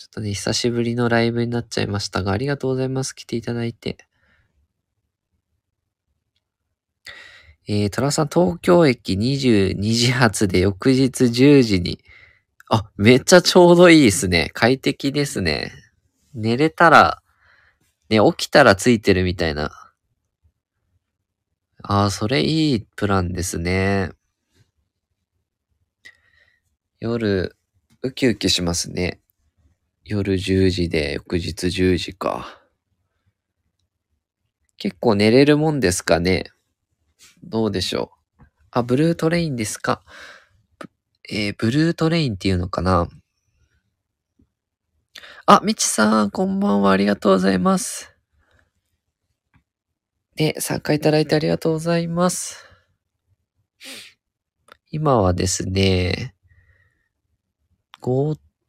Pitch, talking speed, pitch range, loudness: 100 Hz, 210 characters per minute, 90-125 Hz, -18 LUFS